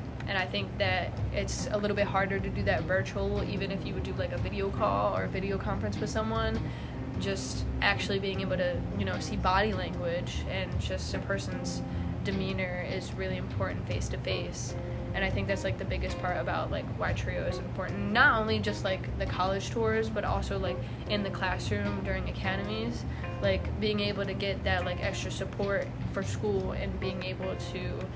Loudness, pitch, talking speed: -31 LUFS, 95 Hz, 200 wpm